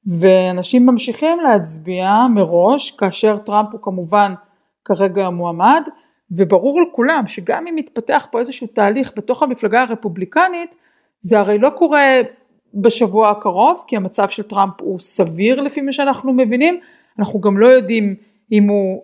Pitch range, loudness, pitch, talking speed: 200-270 Hz, -15 LUFS, 225 Hz, 135 wpm